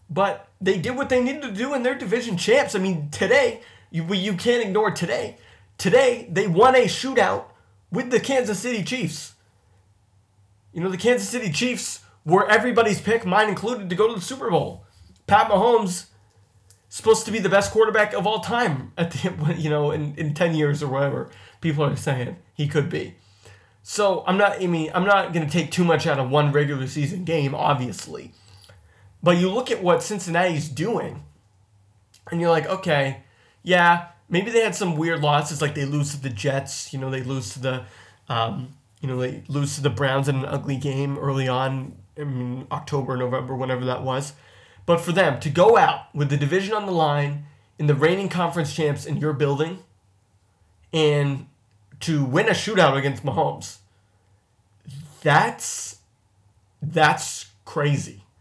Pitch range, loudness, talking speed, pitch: 125-185 Hz, -22 LUFS, 180 wpm, 145 Hz